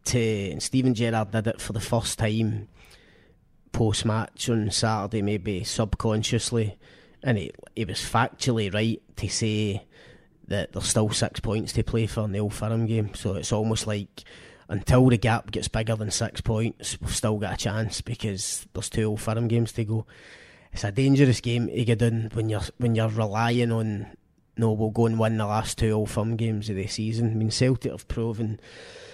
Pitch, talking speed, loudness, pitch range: 110 Hz, 190 wpm, -26 LUFS, 105-115 Hz